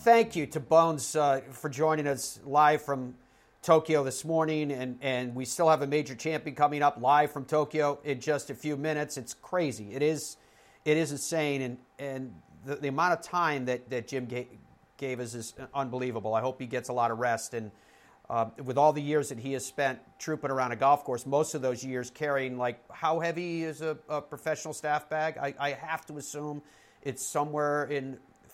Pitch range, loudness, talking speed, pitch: 130-155 Hz, -30 LUFS, 205 wpm, 145 Hz